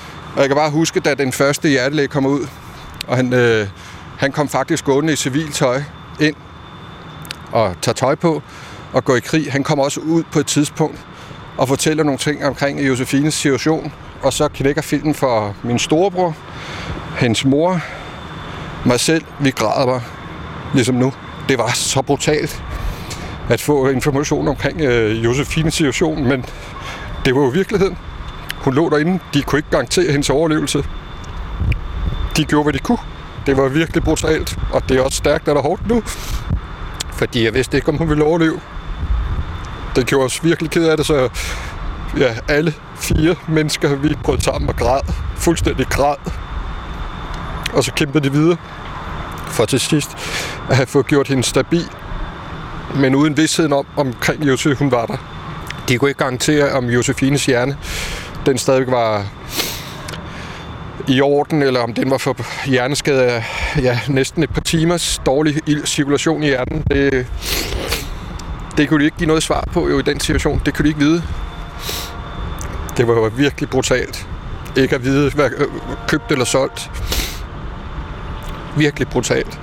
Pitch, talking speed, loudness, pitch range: 140 Hz, 160 wpm, -17 LUFS, 120-150 Hz